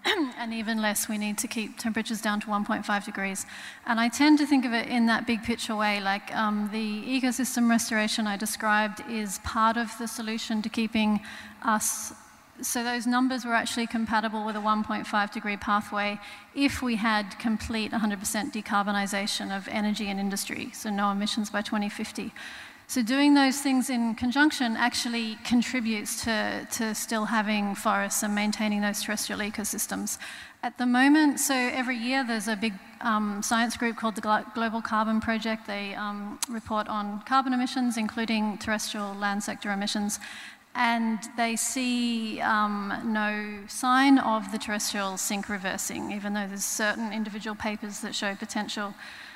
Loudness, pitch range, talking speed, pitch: -27 LUFS, 210-235 Hz, 160 wpm, 220 Hz